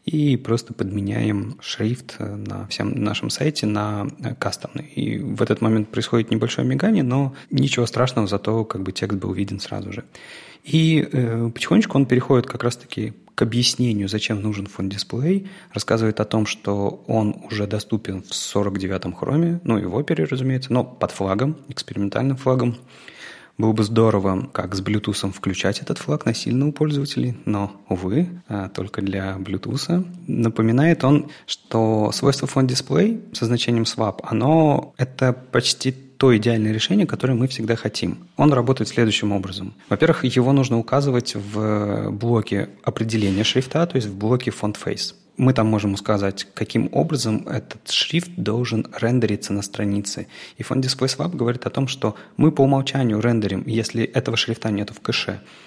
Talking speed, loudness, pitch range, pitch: 155 wpm, -21 LUFS, 105-130 Hz, 115 Hz